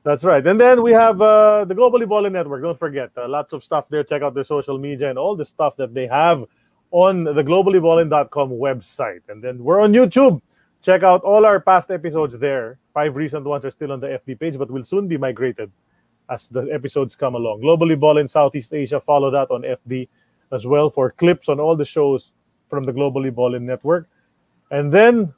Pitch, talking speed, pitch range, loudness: 150 Hz, 210 wpm, 135-180 Hz, -17 LUFS